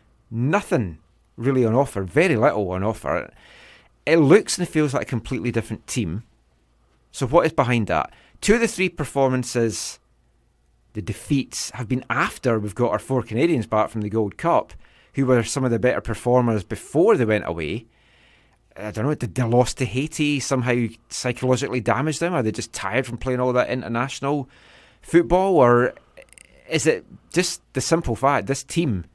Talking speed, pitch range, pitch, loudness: 175 wpm, 110-140 Hz, 125 Hz, -22 LUFS